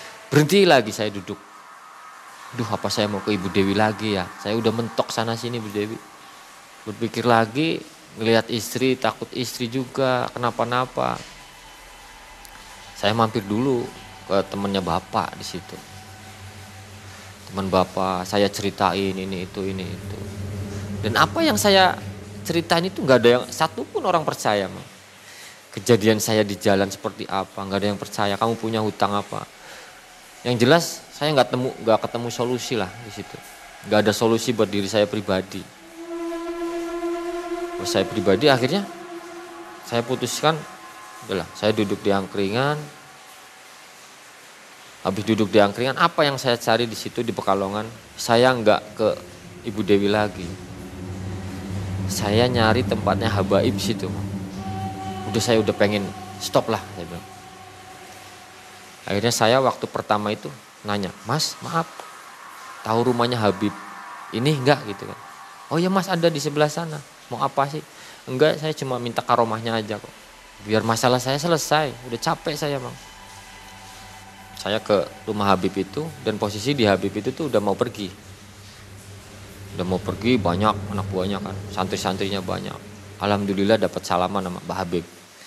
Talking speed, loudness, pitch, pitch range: 140 wpm, -22 LUFS, 105 Hz, 100-125 Hz